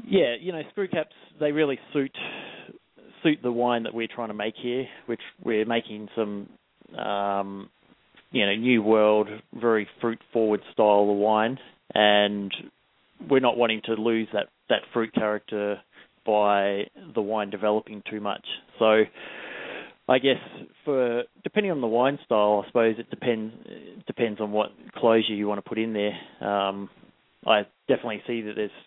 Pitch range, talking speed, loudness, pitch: 105-120 Hz, 160 wpm, -25 LUFS, 110 Hz